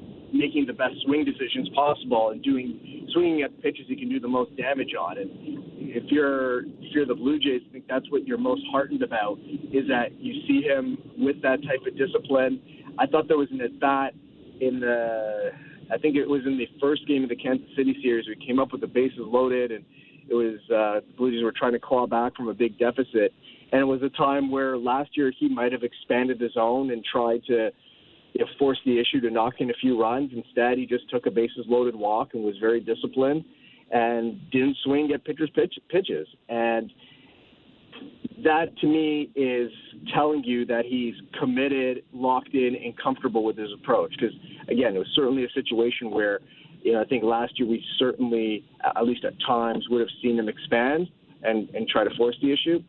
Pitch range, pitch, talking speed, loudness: 120-145 Hz, 130 Hz, 210 wpm, -25 LUFS